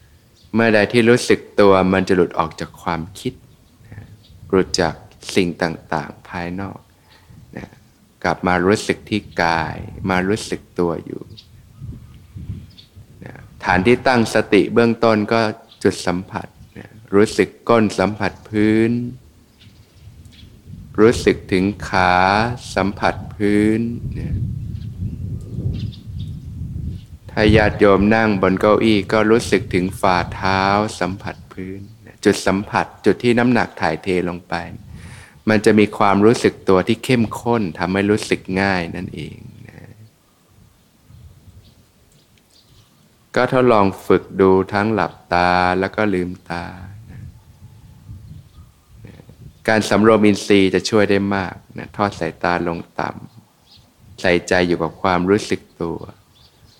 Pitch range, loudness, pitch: 95-110 Hz, -18 LUFS, 105 Hz